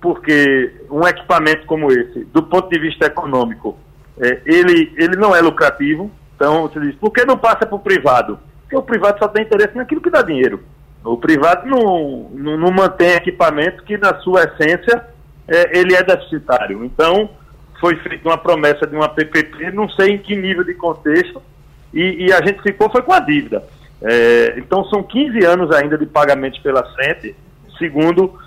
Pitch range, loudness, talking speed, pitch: 155-210 Hz, -14 LUFS, 180 wpm, 175 Hz